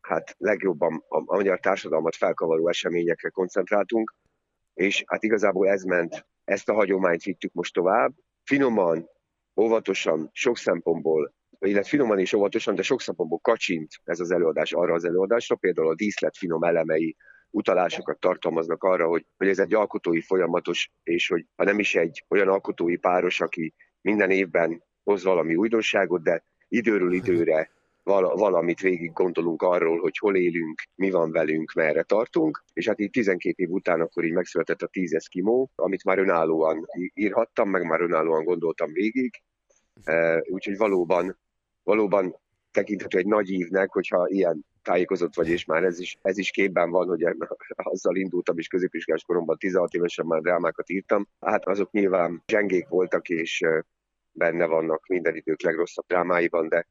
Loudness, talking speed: -24 LUFS, 160 wpm